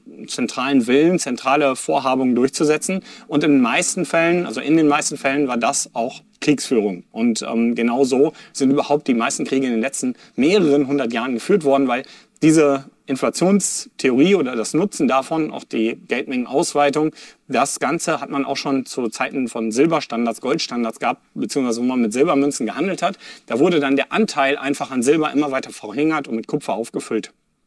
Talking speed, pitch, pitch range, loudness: 175 wpm, 140 Hz, 130-155 Hz, -19 LUFS